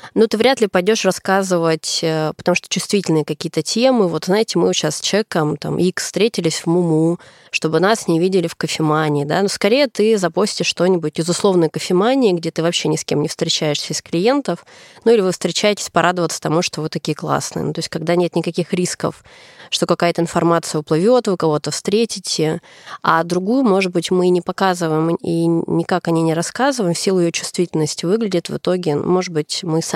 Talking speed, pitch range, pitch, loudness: 190 wpm, 160-190 Hz, 175 Hz, -17 LUFS